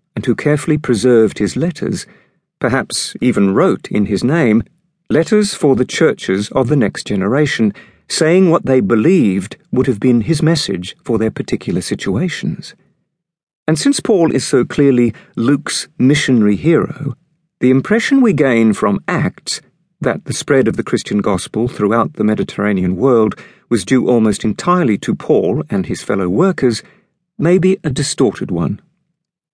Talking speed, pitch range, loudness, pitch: 150 wpm, 120-170 Hz, -15 LUFS, 145 Hz